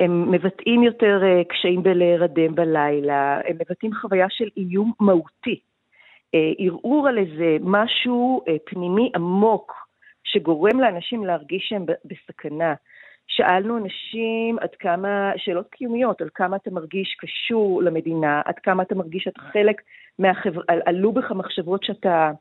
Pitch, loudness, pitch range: 190 Hz, -21 LUFS, 170-215 Hz